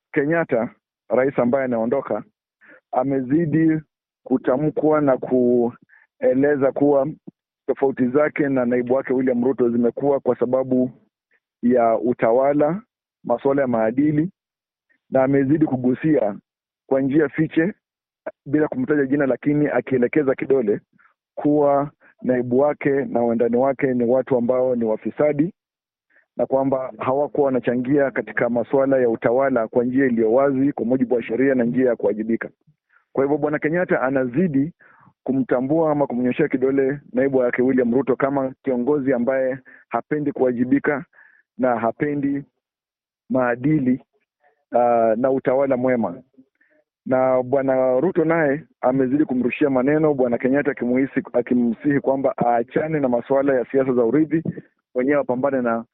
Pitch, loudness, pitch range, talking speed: 135 Hz, -20 LUFS, 125-145 Hz, 120 wpm